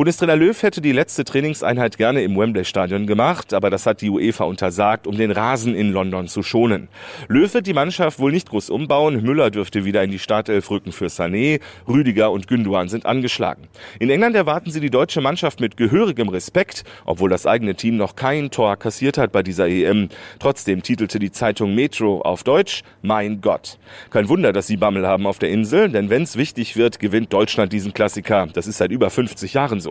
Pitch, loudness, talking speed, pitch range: 110 Hz, -19 LUFS, 205 wpm, 100-140 Hz